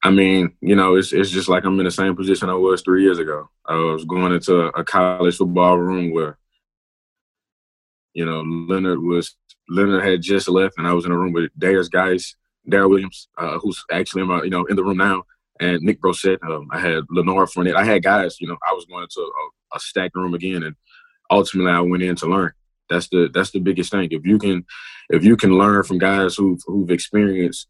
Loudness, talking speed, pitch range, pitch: -18 LUFS, 225 wpm, 85-95 Hz, 90 Hz